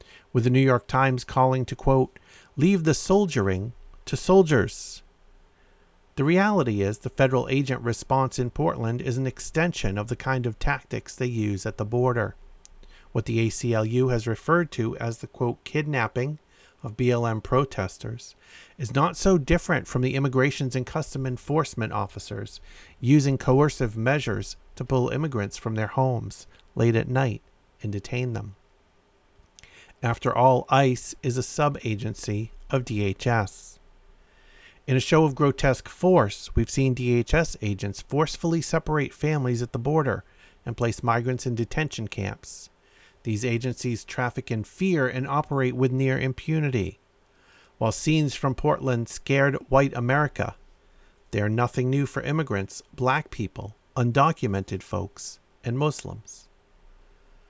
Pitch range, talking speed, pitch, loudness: 105-135 Hz, 140 wpm, 125 Hz, -25 LUFS